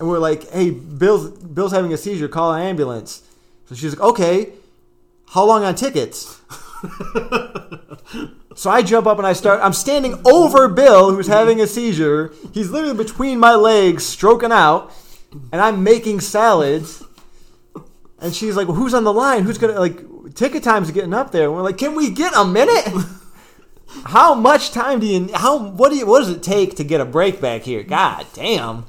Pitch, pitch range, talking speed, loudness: 200 Hz, 175-235 Hz, 190 wpm, -15 LUFS